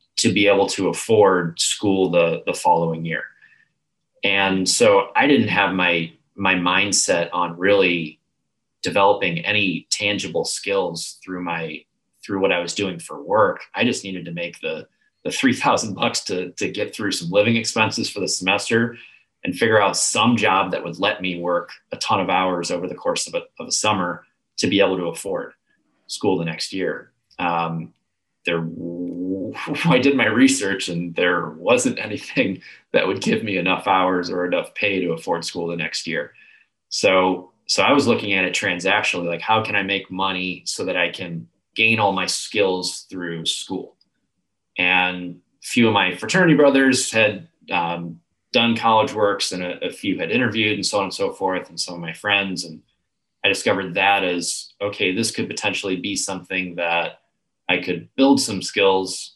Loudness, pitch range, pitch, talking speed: -20 LUFS, 85-105 Hz, 95 Hz, 180 wpm